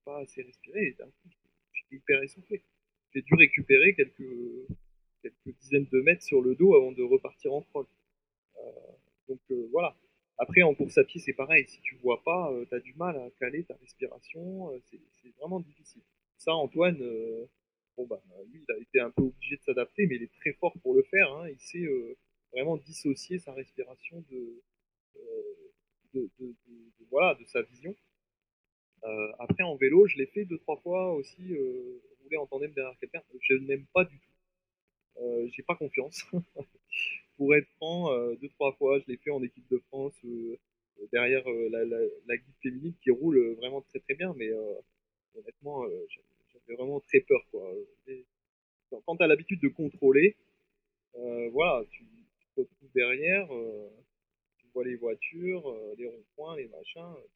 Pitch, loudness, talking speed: 175 Hz, -28 LUFS, 190 wpm